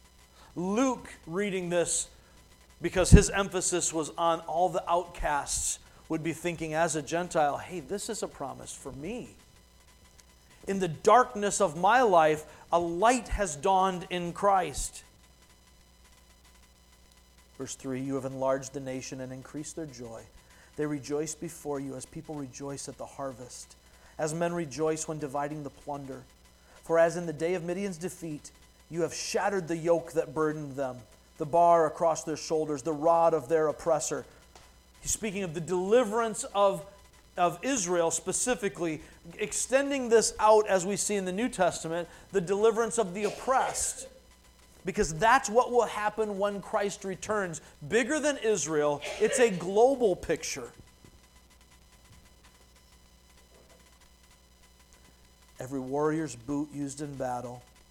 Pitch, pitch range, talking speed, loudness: 160 Hz, 125-190 Hz, 140 wpm, -29 LUFS